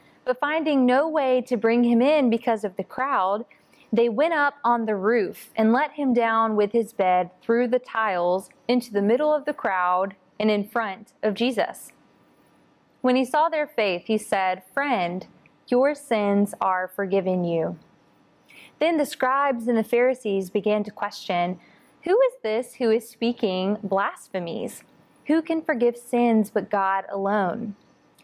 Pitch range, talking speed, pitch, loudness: 200-255 Hz, 160 wpm, 225 Hz, -23 LUFS